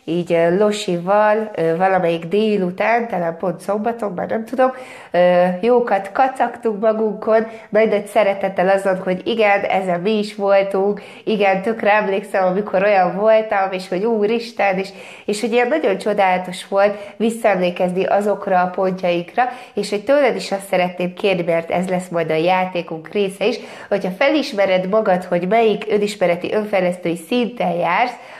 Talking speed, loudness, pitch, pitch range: 140 wpm, -18 LUFS, 200 Hz, 185-215 Hz